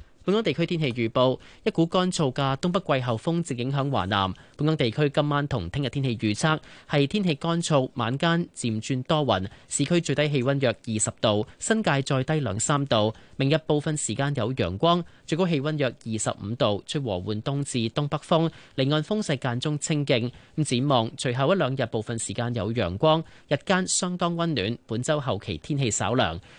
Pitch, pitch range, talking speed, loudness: 140 Hz, 120-155 Hz, 285 characters per minute, -25 LUFS